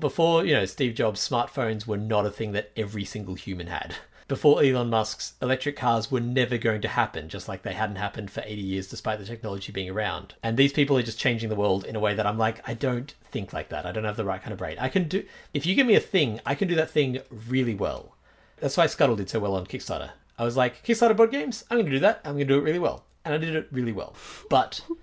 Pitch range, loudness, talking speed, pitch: 105-145 Hz, -26 LUFS, 270 wpm, 120 Hz